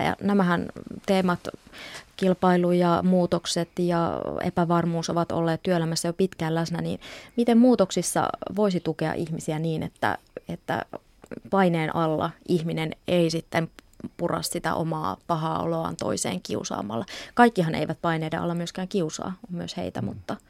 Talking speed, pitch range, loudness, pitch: 130 wpm, 165-185 Hz, -25 LUFS, 170 Hz